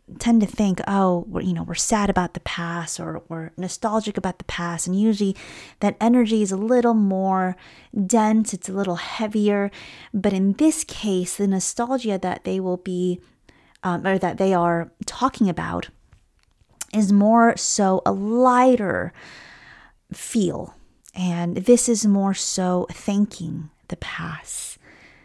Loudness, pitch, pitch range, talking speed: -21 LUFS, 195 Hz, 180-220 Hz, 145 wpm